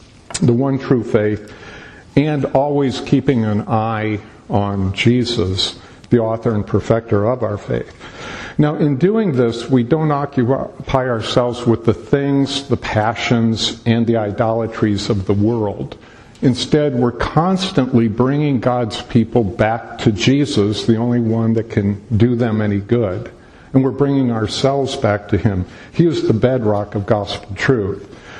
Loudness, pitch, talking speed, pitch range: -17 LUFS, 115 Hz, 145 wpm, 105-135 Hz